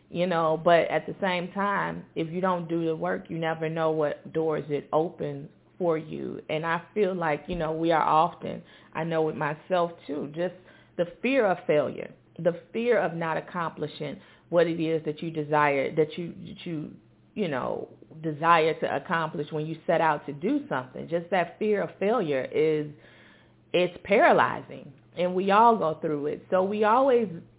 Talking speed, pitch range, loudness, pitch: 185 wpm, 155-180 Hz, -27 LUFS, 165 Hz